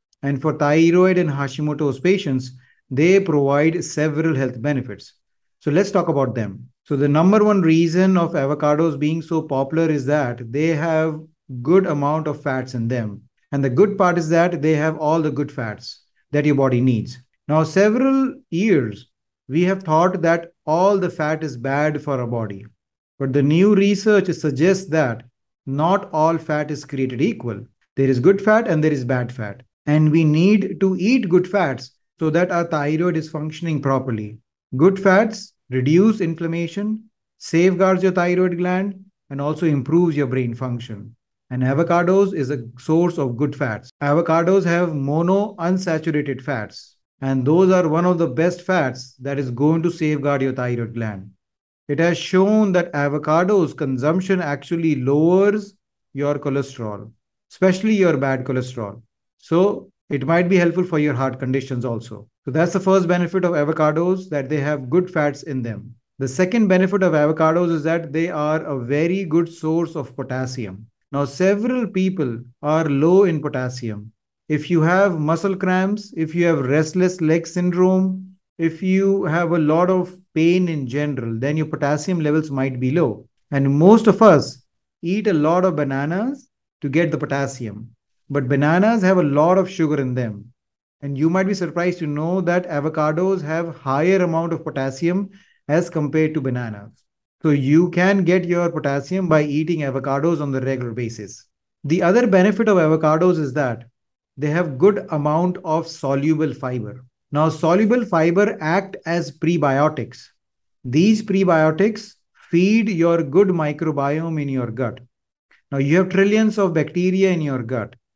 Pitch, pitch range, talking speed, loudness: 155 Hz, 135-180 Hz, 165 wpm, -19 LUFS